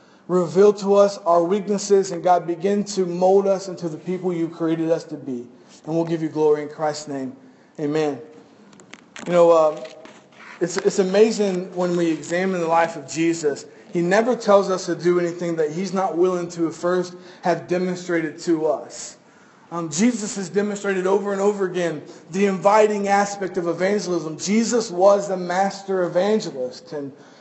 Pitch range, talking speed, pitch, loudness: 165-195 Hz, 170 wpm, 180 Hz, -21 LUFS